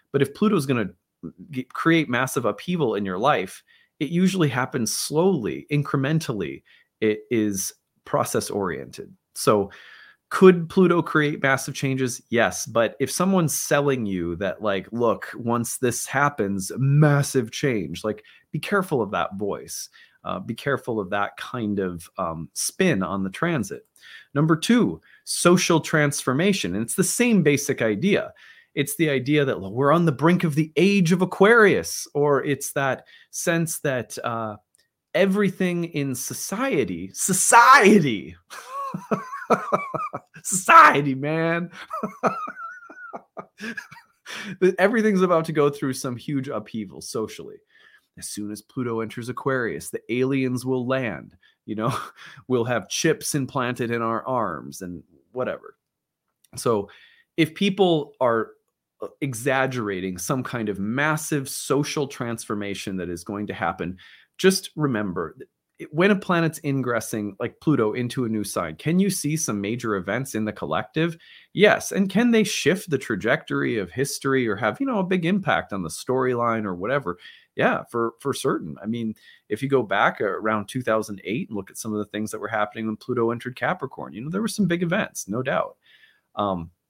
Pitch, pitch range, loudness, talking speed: 135 Hz, 115-175 Hz, -23 LUFS, 150 wpm